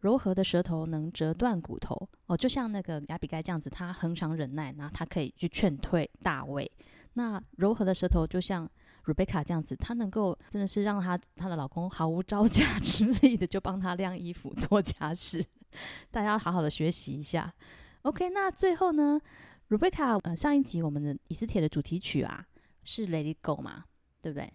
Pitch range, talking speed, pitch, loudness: 160-210 Hz, 300 characters per minute, 180 Hz, -31 LUFS